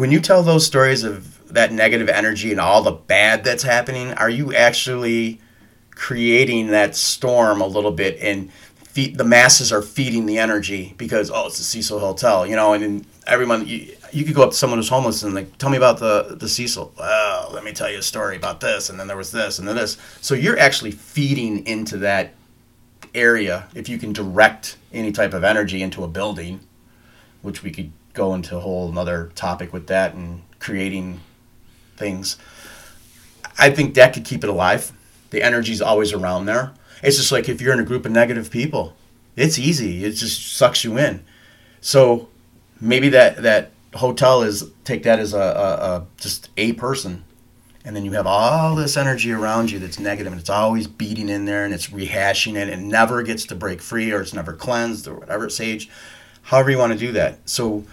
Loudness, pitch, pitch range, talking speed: -18 LUFS, 115 Hz, 100-120 Hz, 205 wpm